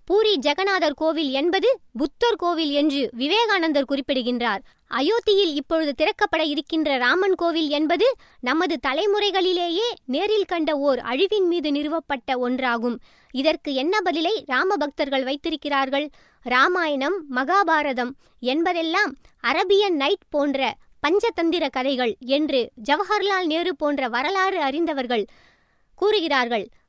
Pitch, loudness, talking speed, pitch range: 315 Hz, -22 LUFS, 105 wpm, 275-375 Hz